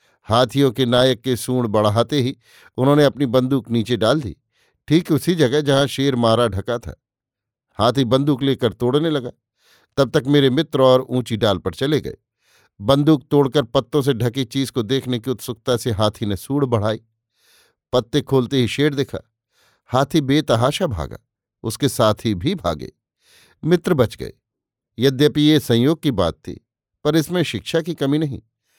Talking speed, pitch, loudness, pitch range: 165 wpm, 130 Hz, -19 LUFS, 115-145 Hz